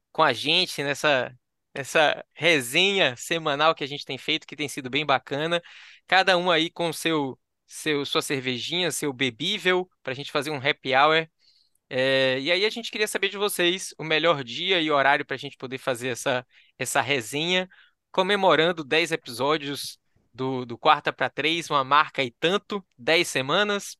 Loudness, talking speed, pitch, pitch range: -24 LUFS, 175 wpm, 150 Hz, 135-170 Hz